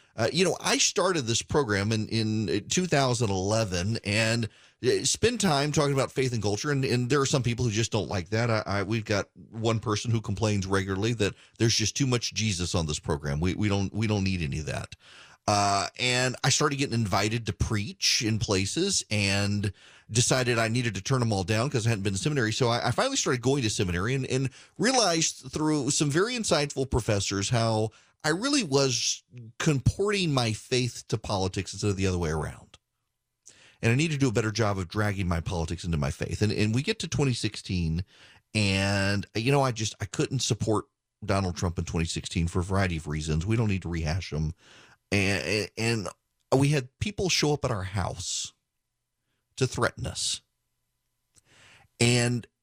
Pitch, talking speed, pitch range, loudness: 110 Hz, 195 wpm, 100-130 Hz, -27 LUFS